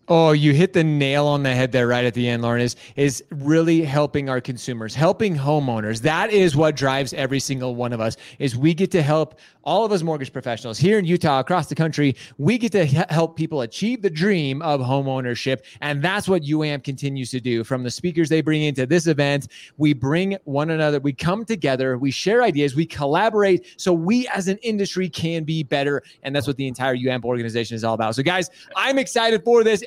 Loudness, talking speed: -21 LUFS, 215 wpm